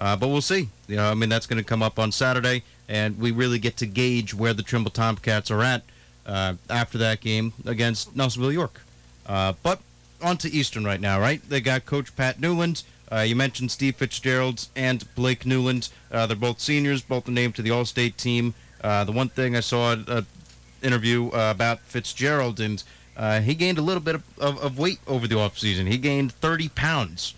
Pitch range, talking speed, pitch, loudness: 110-130 Hz, 210 wpm, 120 Hz, -24 LUFS